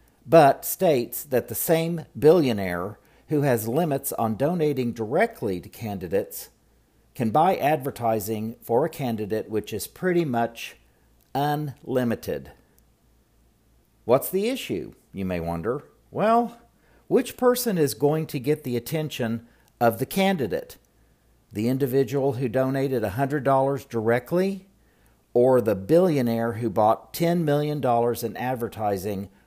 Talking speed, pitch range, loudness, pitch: 125 wpm, 115-150 Hz, -24 LUFS, 130 Hz